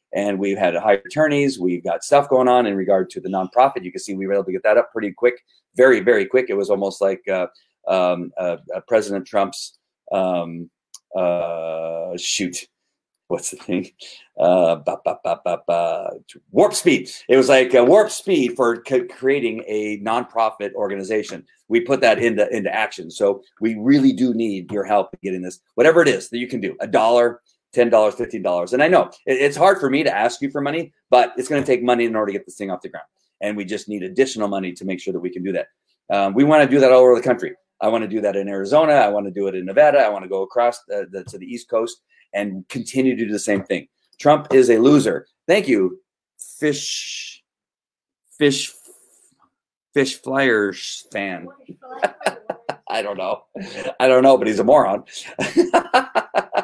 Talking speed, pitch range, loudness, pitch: 210 wpm, 100-135 Hz, -19 LUFS, 115 Hz